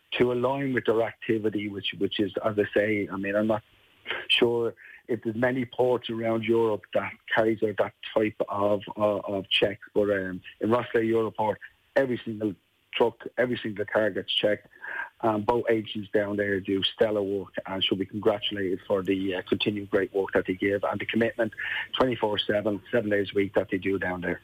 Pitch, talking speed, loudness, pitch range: 105 Hz, 195 wpm, -27 LUFS, 100-115 Hz